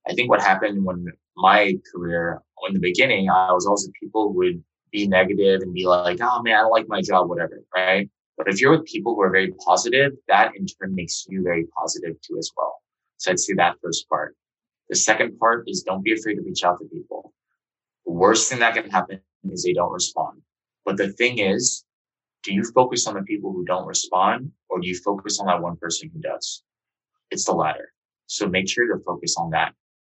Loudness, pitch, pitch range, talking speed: -21 LUFS, 95 Hz, 90-110 Hz, 215 wpm